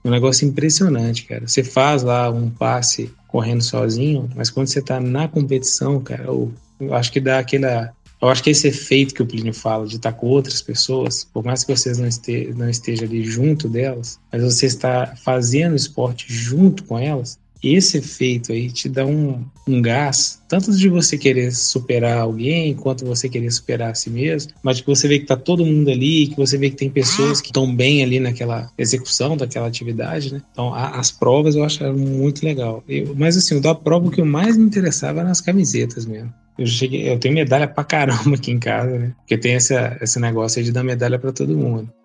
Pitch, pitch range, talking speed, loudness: 130 Hz, 120-145 Hz, 210 wpm, -18 LUFS